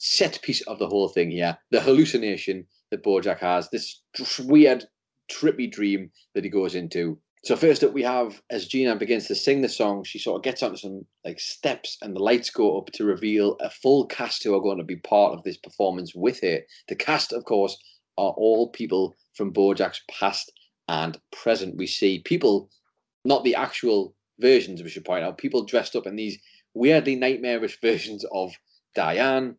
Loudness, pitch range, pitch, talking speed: -24 LUFS, 95-125 Hz, 105 Hz, 195 wpm